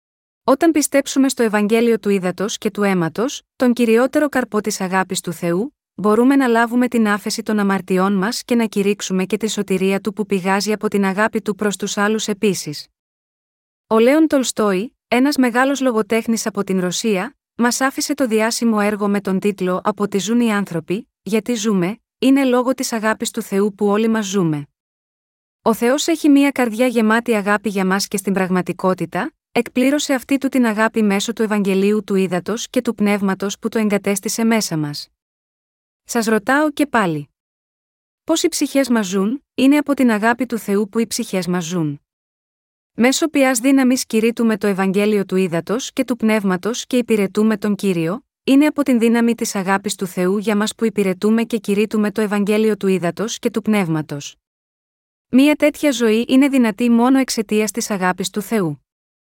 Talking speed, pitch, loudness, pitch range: 175 wpm, 220 Hz, -18 LUFS, 200-245 Hz